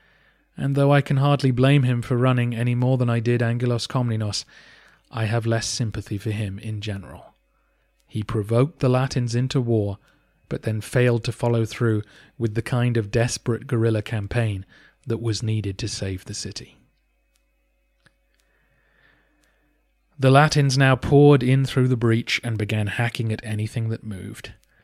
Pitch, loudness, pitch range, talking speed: 115 Hz, -22 LUFS, 110-125 Hz, 155 wpm